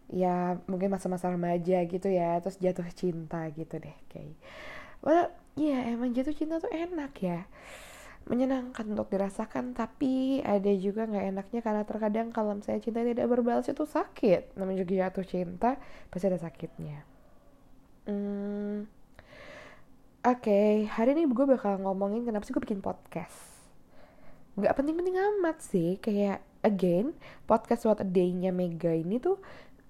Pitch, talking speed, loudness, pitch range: 205 Hz, 140 wpm, -30 LUFS, 185-245 Hz